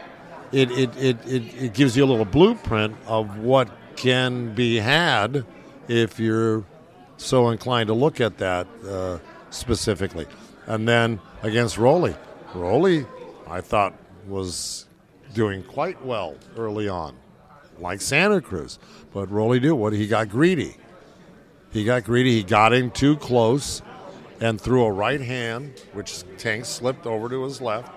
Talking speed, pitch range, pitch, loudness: 145 wpm, 105-130 Hz, 115 Hz, -22 LUFS